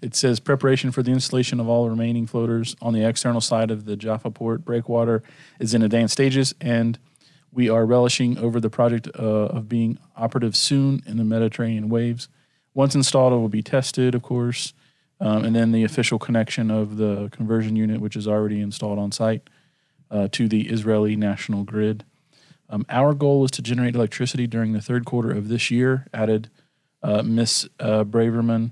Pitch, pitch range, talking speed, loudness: 115 Hz, 110-130 Hz, 185 wpm, -22 LUFS